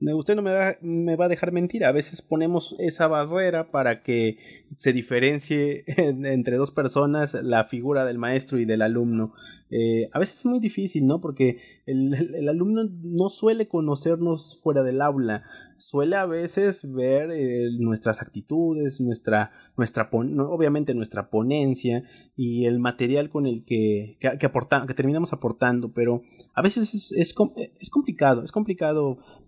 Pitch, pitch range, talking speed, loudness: 140 Hz, 120-165 Hz, 165 wpm, -24 LUFS